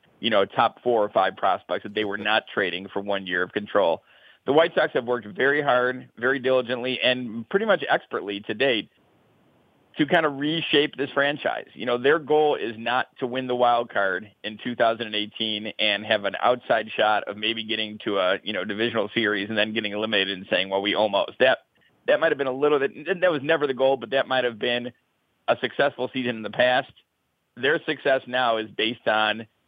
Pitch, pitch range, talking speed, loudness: 120 Hz, 105-130 Hz, 210 wpm, -24 LUFS